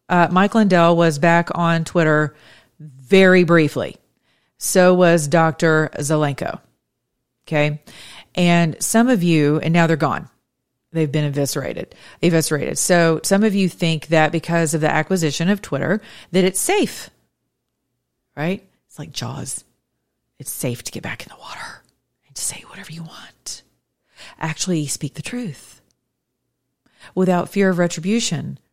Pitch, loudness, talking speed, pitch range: 165 Hz, -18 LUFS, 140 wpm, 155-180 Hz